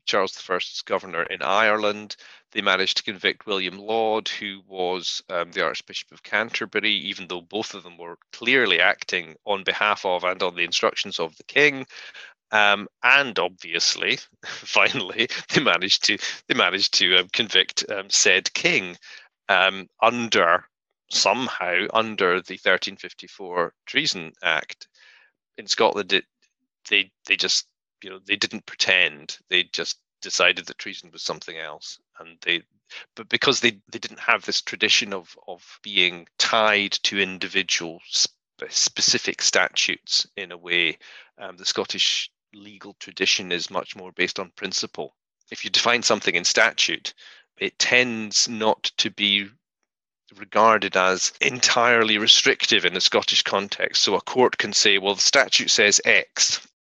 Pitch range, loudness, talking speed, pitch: 95-110 Hz, -21 LUFS, 150 wpm, 100 Hz